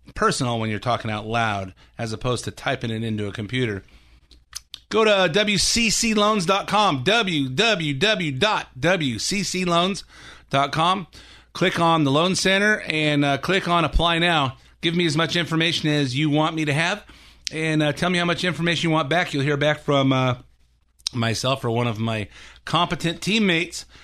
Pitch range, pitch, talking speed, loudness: 125-175 Hz, 155 Hz, 155 wpm, -21 LUFS